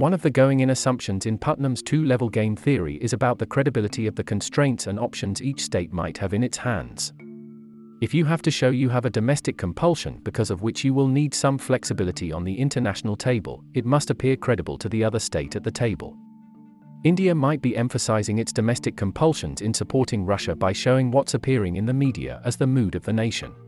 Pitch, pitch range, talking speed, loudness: 120 Hz, 105-135 Hz, 215 wpm, -23 LUFS